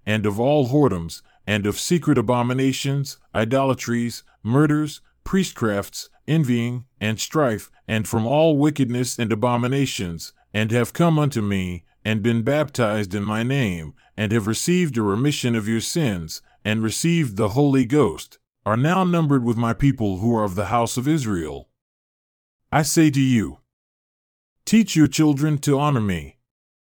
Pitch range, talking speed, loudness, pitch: 110-145 Hz, 150 wpm, -21 LUFS, 120 Hz